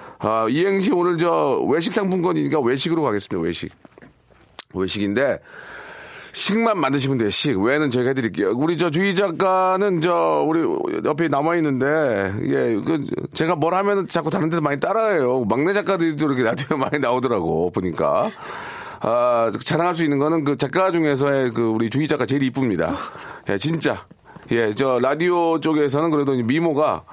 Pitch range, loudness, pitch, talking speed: 135-185 Hz, -20 LUFS, 160 Hz, 345 characters per minute